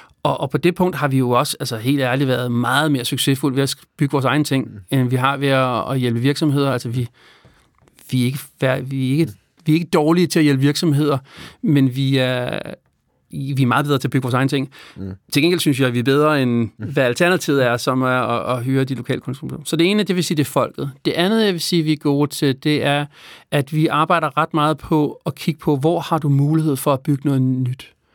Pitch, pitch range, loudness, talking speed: 140 Hz, 130-155 Hz, -18 LUFS, 245 wpm